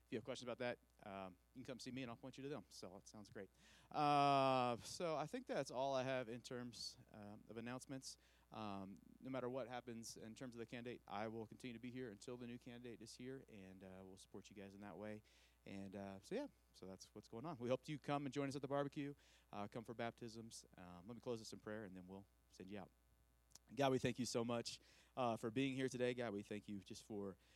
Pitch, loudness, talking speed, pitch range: 115 Hz, -48 LUFS, 260 wpm, 100-130 Hz